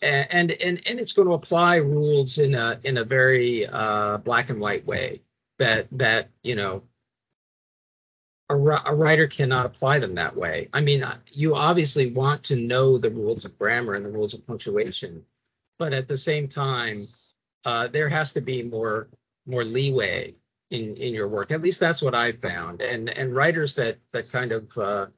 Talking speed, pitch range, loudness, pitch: 185 wpm, 120-150 Hz, -23 LUFS, 135 Hz